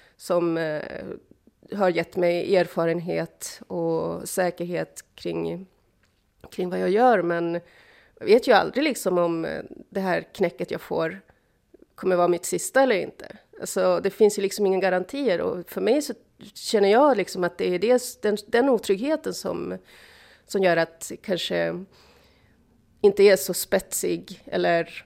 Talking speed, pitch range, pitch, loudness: 145 wpm, 170-205 Hz, 180 Hz, -24 LUFS